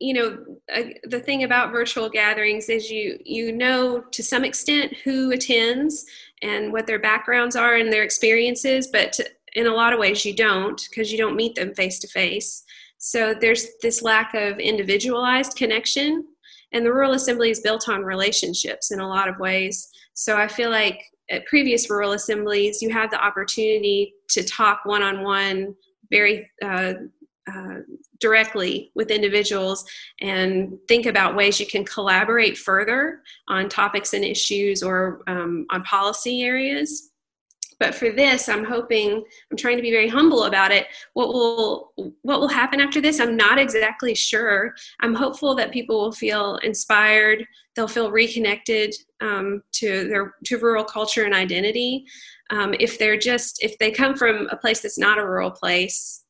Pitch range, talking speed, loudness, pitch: 205-245 Hz, 170 wpm, -20 LUFS, 225 Hz